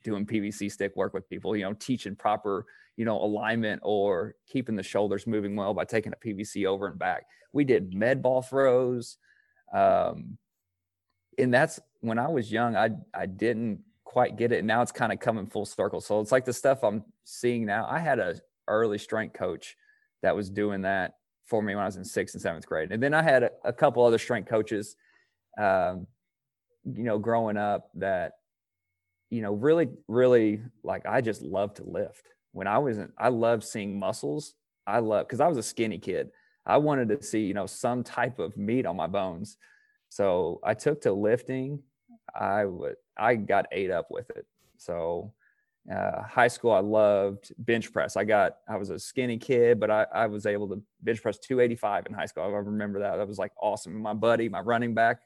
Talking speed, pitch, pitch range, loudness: 200 wpm, 115 Hz, 105-130 Hz, -28 LUFS